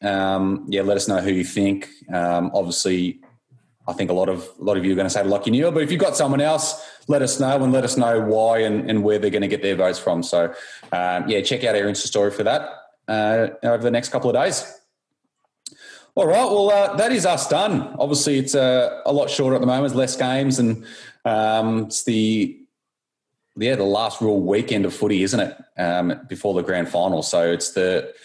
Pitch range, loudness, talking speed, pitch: 95-135 Hz, -20 LUFS, 225 wpm, 110 Hz